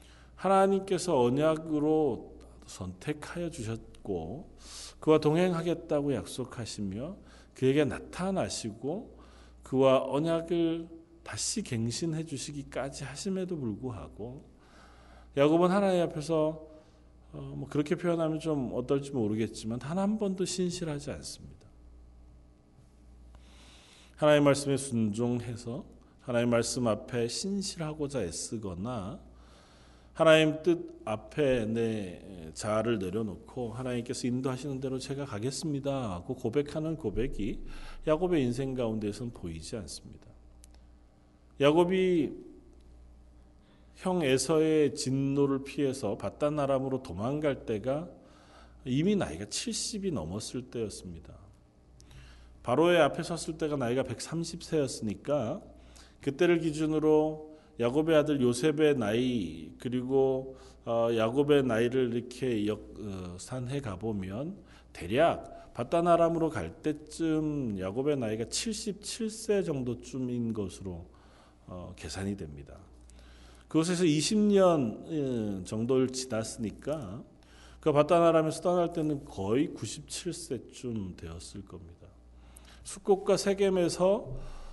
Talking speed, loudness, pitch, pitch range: 245 characters per minute, -30 LUFS, 130 Hz, 95-155 Hz